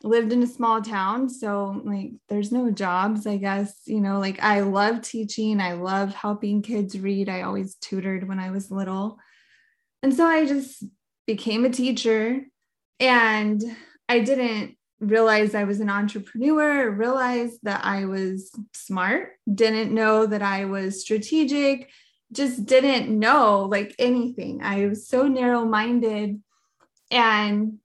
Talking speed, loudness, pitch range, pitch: 140 wpm, -23 LUFS, 200-245 Hz, 215 Hz